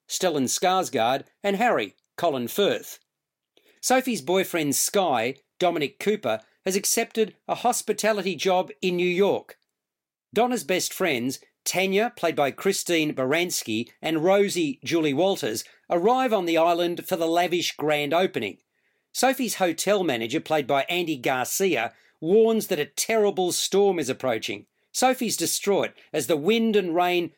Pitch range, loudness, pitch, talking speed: 165-205 Hz, -24 LUFS, 185 Hz, 135 wpm